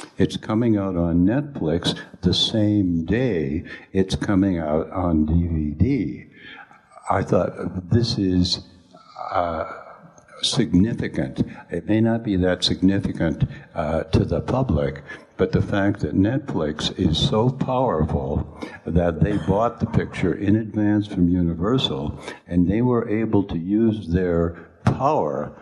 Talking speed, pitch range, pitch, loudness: 125 wpm, 85-105 Hz, 95 Hz, -22 LUFS